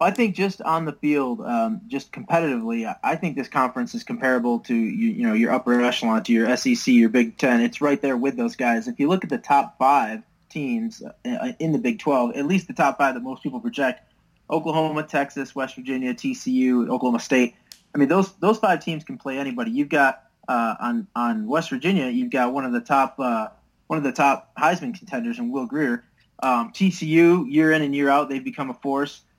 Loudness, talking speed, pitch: -22 LUFS, 215 wpm, 160 Hz